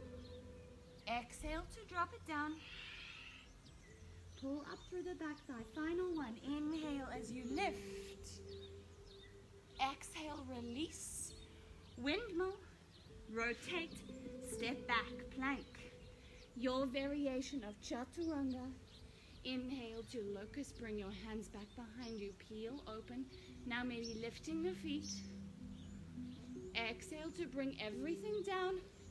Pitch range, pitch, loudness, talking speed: 195-295 Hz, 245 Hz, -45 LUFS, 100 wpm